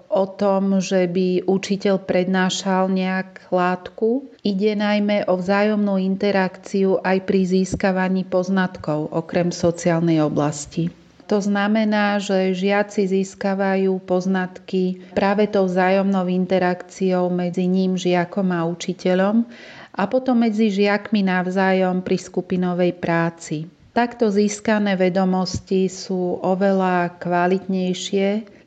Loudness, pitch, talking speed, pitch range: -20 LUFS, 190 Hz, 105 wpm, 180-200 Hz